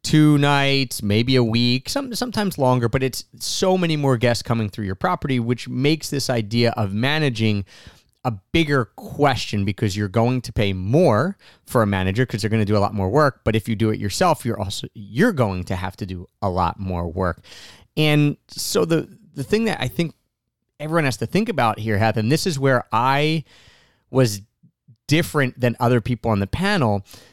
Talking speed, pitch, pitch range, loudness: 200 wpm, 120 Hz, 105-145 Hz, -21 LUFS